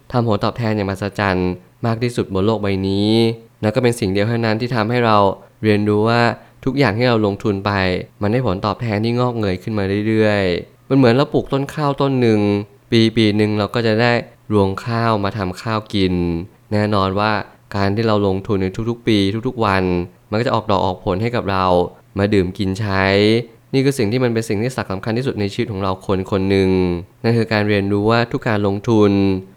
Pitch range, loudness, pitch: 100-115 Hz, -18 LUFS, 105 Hz